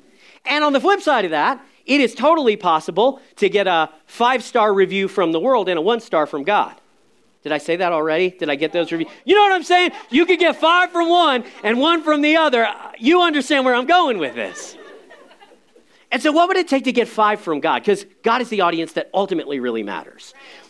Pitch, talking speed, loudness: 245 Hz, 230 wpm, -17 LUFS